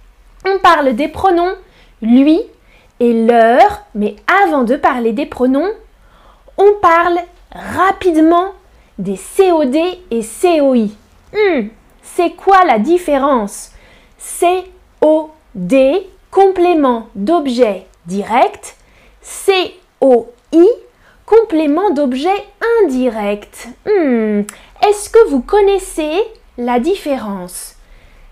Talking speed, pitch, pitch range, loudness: 85 wpm, 330 Hz, 245-380 Hz, -13 LUFS